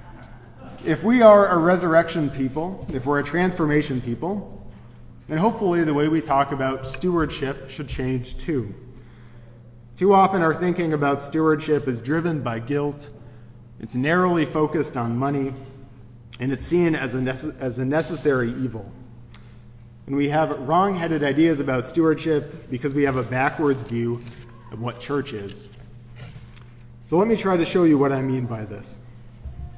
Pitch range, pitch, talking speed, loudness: 120-160 Hz, 135 Hz, 155 wpm, -22 LUFS